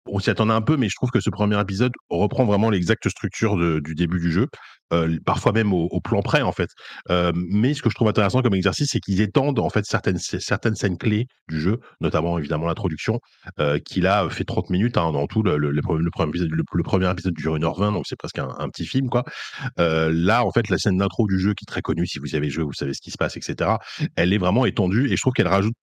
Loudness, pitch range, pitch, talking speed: -22 LUFS, 85-110 Hz, 100 Hz, 270 wpm